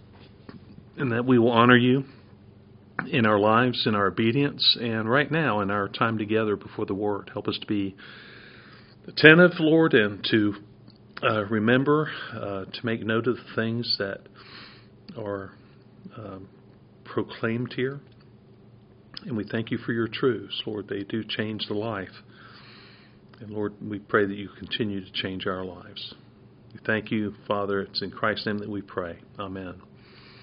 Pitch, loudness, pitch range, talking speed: 110 Hz, -25 LUFS, 100-120 Hz, 160 wpm